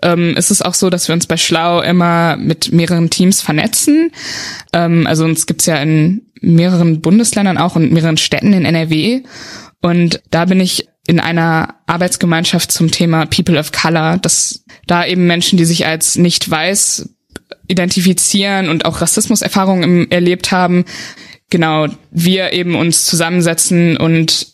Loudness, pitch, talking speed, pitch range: -12 LUFS, 170 Hz, 155 wpm, 165-185 Hz